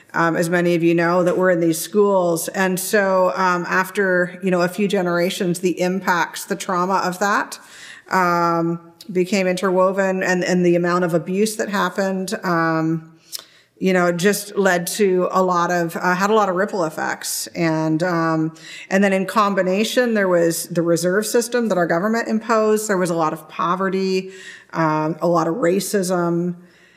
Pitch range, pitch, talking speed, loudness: 170-195 Hz, 180 Hz, 175 wpm, -19 LUFS